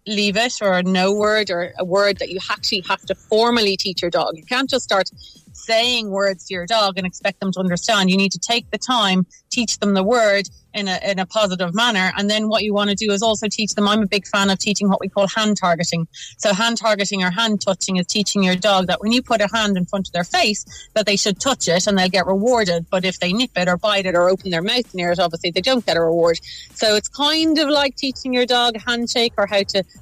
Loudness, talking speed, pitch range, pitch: -18 LUFS, 265 wpm, 185-225 Hz, 200 Hz